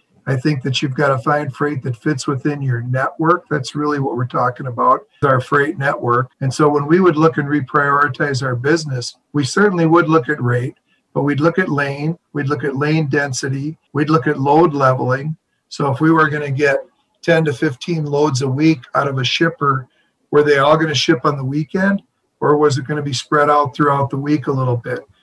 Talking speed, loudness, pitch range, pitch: 220 wpm, -17 LUFS, 135-155 Hz, 145 Hz